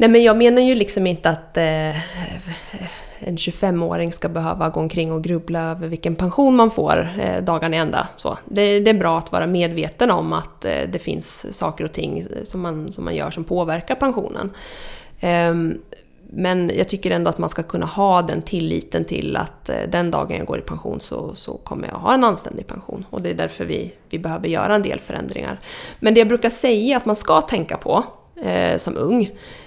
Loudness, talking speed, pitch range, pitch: -20 LUFS, 205 wpm, 165-210 Hz, 175 Hz